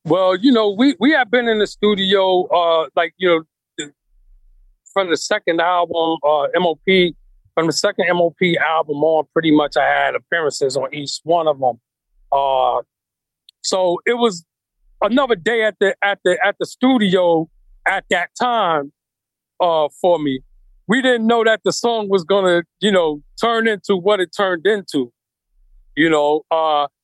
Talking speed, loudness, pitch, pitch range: 165 wpm, -17 LUFS, 175 Hz, 150-205 Hz